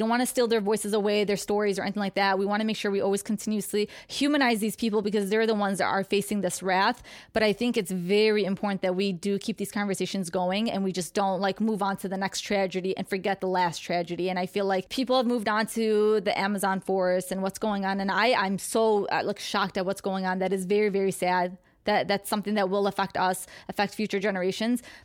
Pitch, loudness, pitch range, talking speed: 200 Hz, -27 LUFS, 190-215 Hz, 245 wpm